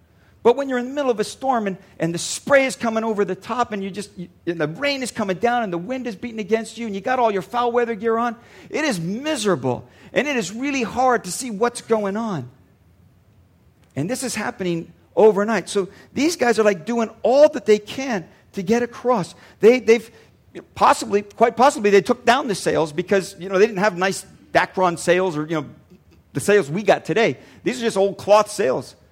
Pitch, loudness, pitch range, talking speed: 215 Hz, -20 LUFS, 185-240 Hz, 220 wpm